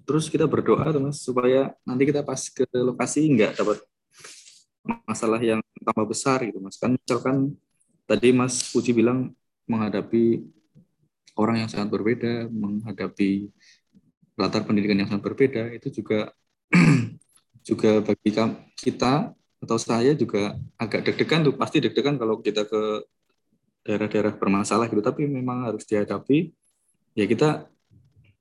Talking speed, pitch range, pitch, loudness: 125 wpm, 105-130 Hz, 115 Hz, -24 LUFS